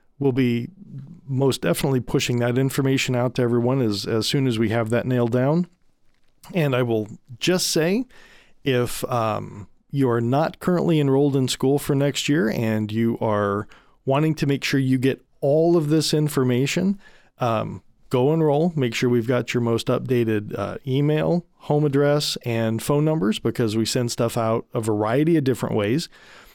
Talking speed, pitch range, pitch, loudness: 170 wpm, 120-150 Hz, 130 Hz, -22 LUFS